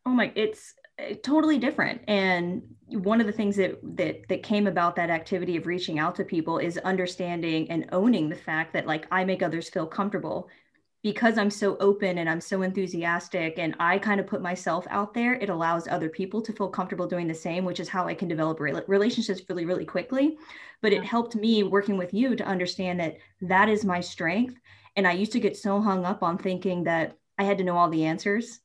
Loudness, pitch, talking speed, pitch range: -27 LUFS, 190 Hz, 215 wpm, 175-210 Hz